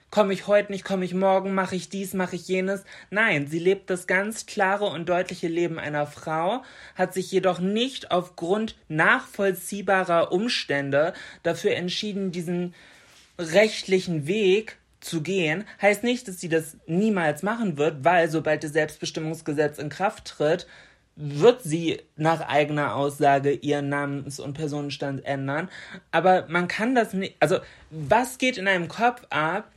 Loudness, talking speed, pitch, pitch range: -25 LUFS, 150 wpm, 180 Hz, 155-195 Hz